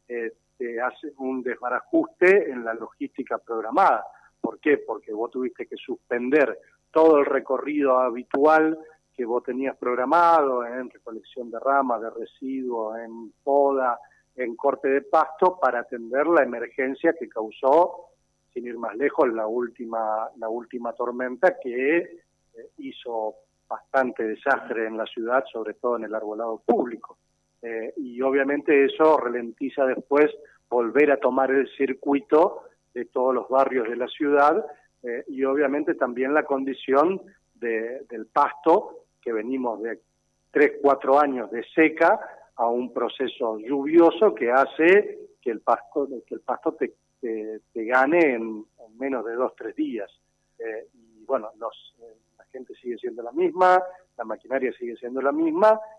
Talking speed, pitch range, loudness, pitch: 150 wpm, 120-165 Hz, -24 LUFS, 135 Hz